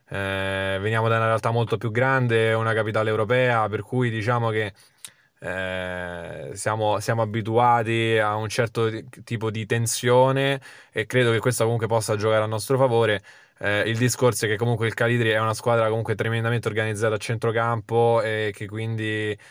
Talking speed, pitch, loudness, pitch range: 170 wpm, 115 Hz, -23 LUFS, 110-115 Hz